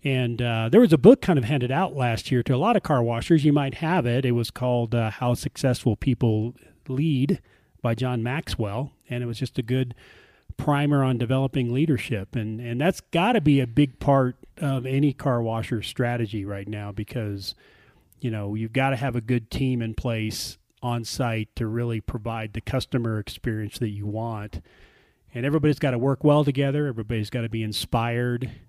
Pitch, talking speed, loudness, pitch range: 125 Hz, 195 wpm, -24 LUFS, 115-135 Hz